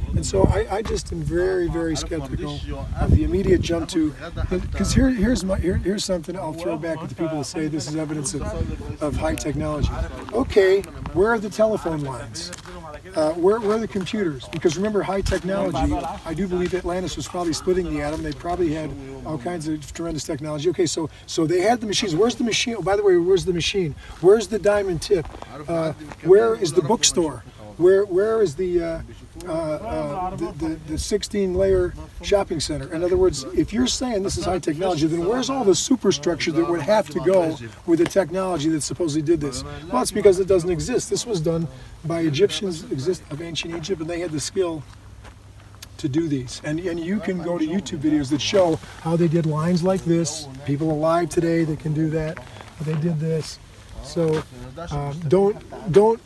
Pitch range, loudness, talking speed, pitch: 155-195 Hz, -22 LUFS, 200 wpm, 170 Hz